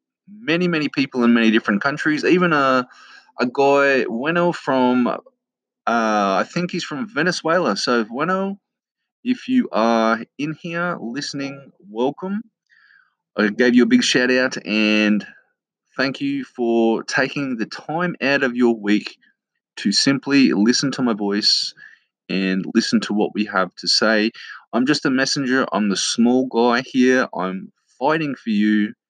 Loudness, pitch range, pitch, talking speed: -19 LUFS, 115-155 Hz, 130 Hz, 150 wpm